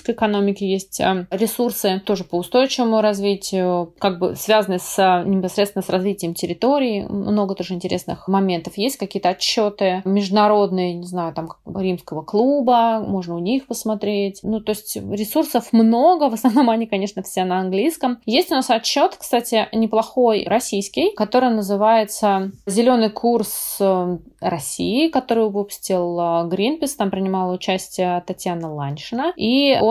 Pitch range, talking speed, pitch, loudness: 185-230 Hz, 135 wpm, 205 Hz, -19 LUFS